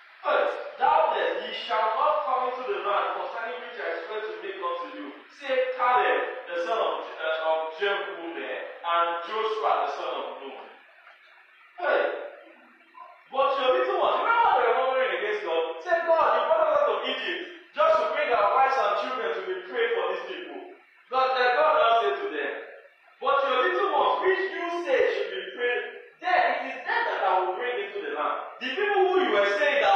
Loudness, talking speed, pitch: -26 LUFS, 205 wpm, 300 Hz